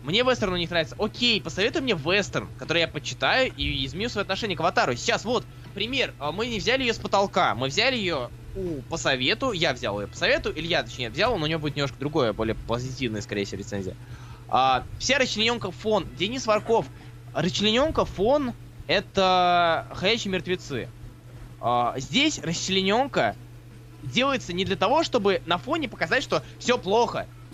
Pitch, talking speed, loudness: 170 Hz, 165 wpm, -25 LUFS